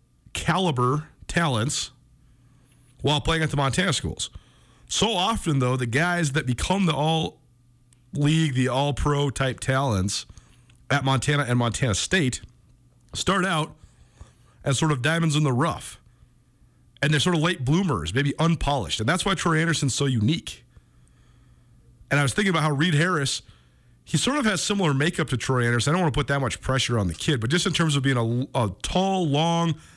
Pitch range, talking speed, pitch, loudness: 120-160 Hz, 180 wpm, 140 Hz, -23 LUFS